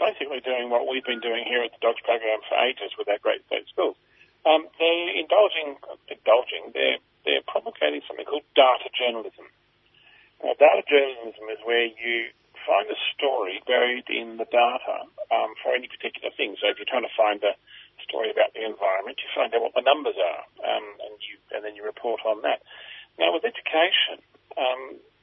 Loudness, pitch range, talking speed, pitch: -24 LUFS, 110-160 Hz, 185 wpm, 120 Hz